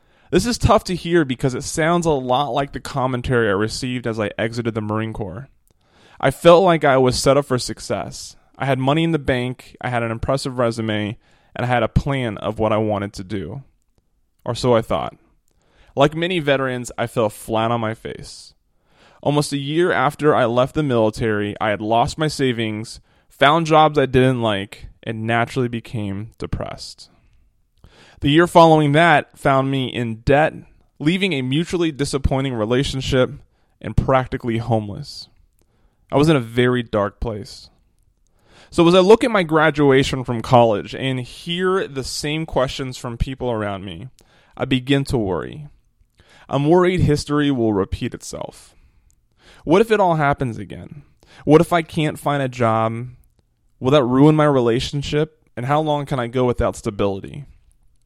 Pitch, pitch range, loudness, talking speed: 130 Hz, 115-145 Hz, -19 LUFS, 170 wpm